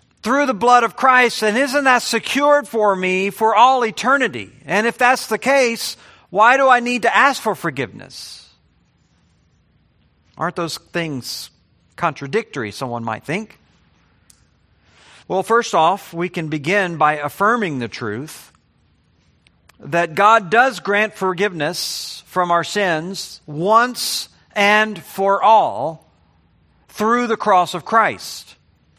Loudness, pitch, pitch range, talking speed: -17 LUFS, 195 Hz, 150-230 Hz, 125 wpm